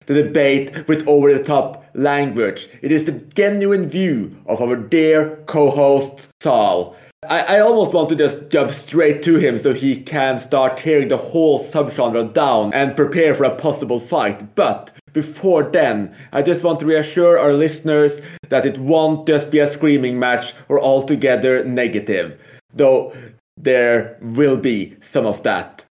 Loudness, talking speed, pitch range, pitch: -16 LUFS, 160 wpm, 130-155 Hz, 145 Hz